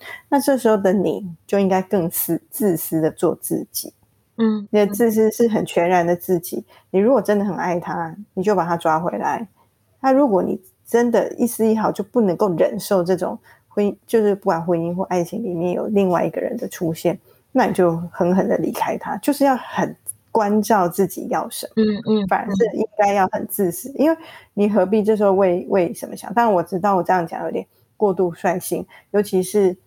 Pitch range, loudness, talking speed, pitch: 180-220 Hz, -20 LUFS, 290 characters per minute, 200 Hz